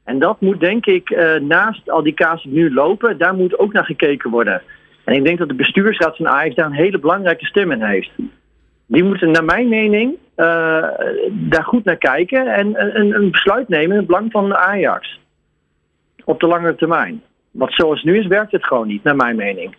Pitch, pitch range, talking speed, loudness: 185 Hz, 160-220 Hz, 205 wpm, -15 LUFS